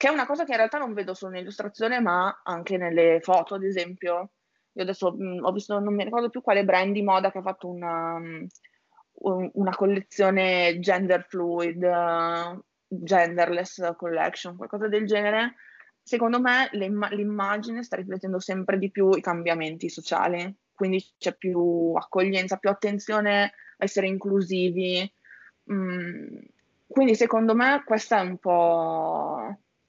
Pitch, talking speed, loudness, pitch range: 190 Hz, 150 wpm, -25 LUFS, 180-210 Hz